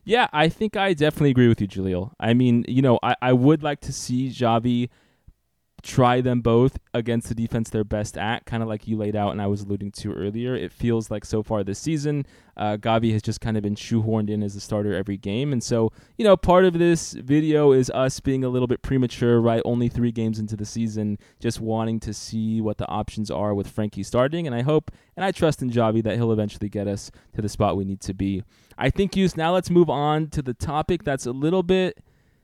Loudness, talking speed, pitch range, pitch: -23 LUFS, 240 wpm, 105-135 Hz, 115 Hz